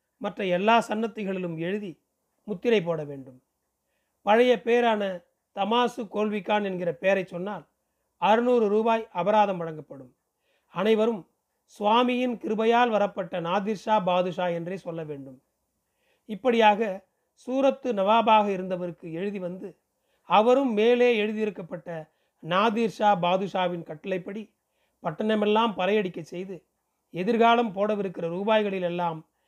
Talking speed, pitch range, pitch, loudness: 90 wpm, 180-225 Hz, 205 Hz, -25 LUFS